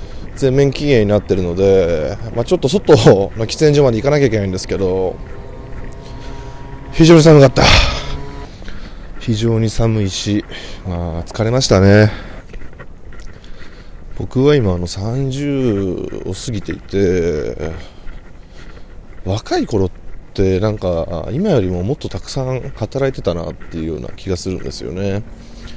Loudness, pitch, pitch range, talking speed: -15 LUFS, 100 Hz, 90-120 Hz, 255 characters per minute